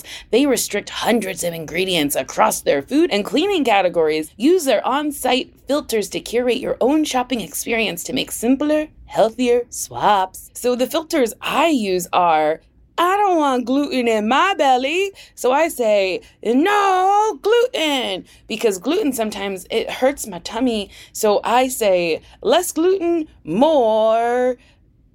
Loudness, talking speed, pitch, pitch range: -18 LUFS, 135 wpm, 250 Hz, 205-305 Hz